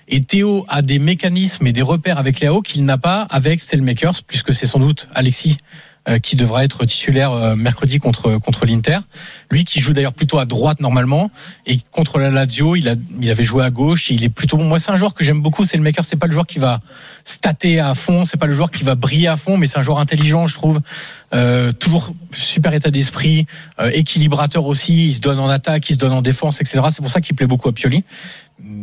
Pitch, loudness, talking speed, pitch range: 150 Hz, -15 LUFS, 235 wpm, 135-165 Hz